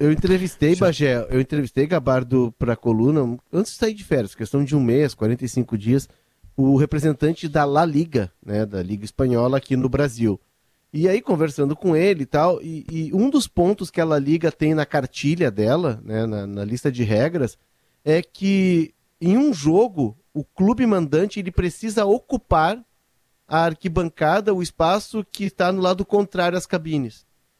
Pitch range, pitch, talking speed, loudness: 130-185 Hz, 155 Hz, 170 wpm, -21 LUFS